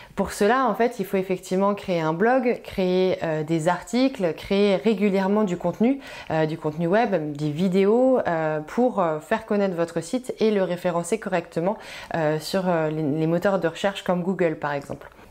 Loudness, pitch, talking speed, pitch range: -23 LUFS, 185 Hz, 175 wpm, 165-210 Hz